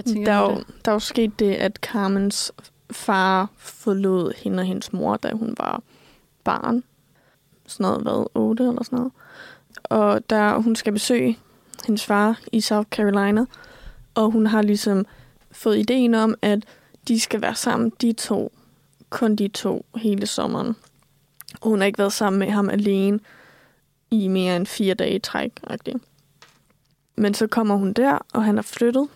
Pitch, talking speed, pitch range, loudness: 215 Hz, 160 wpm, 200-230 Hz, -22 LUFS